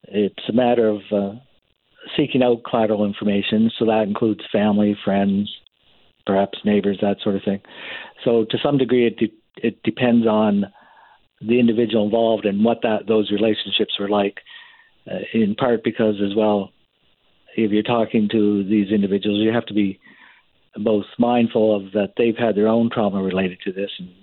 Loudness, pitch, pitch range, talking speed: -20 LUFS, 110 Hz, 100-115 Hz, 170 wpm